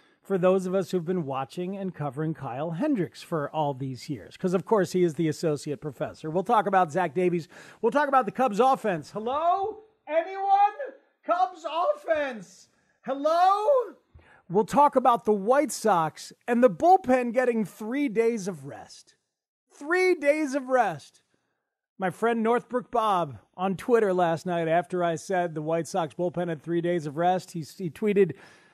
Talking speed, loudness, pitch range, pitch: 165 wpm, -26 LUFS, 170-270 Hz, 200 Hz